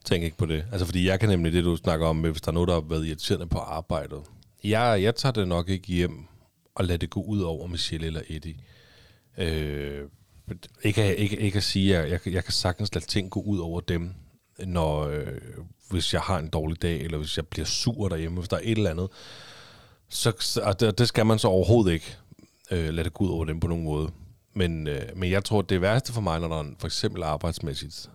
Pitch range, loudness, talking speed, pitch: 80-105 Hz, -27 LUFS, 230 wpm, 90 Hz